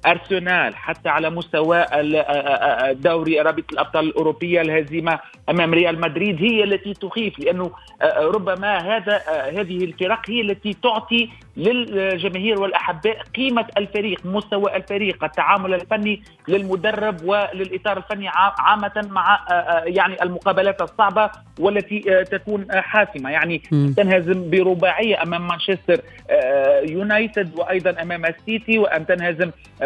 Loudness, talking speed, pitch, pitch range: -19 LUFS, 105 wpm, 190 Hz, 170-205 Hz